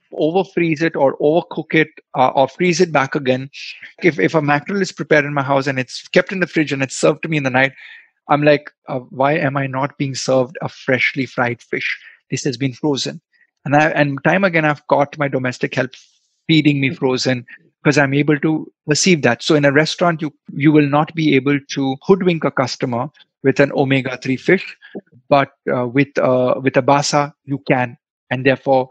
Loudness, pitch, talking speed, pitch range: -17 LUFS, 145 Hz, 210 wpm, 135-155 Hz